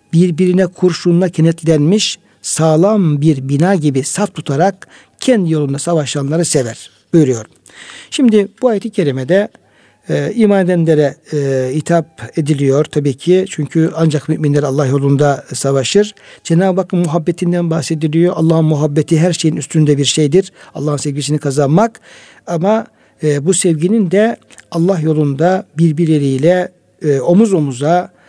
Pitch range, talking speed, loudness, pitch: 145-180 Hz, 120 wpm, -13 LUFS, 165 Hz